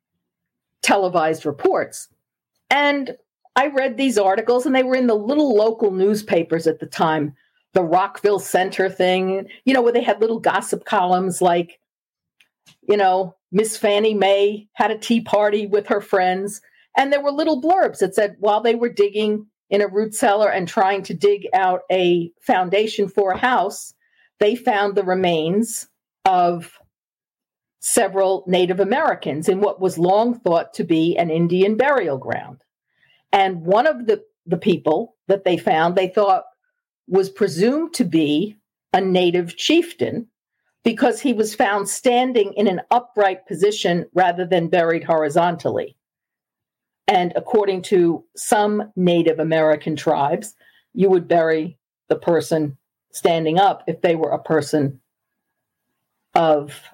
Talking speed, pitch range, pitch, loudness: 145 wpm, 175-230 Hz, 200 Hz, -19 LUFS